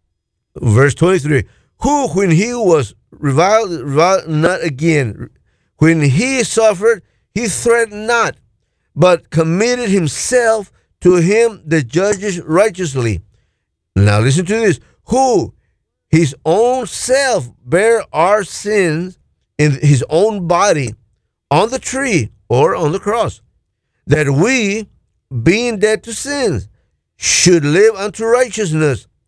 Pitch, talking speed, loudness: 170 Hz, 115 wpm, -14 LUFS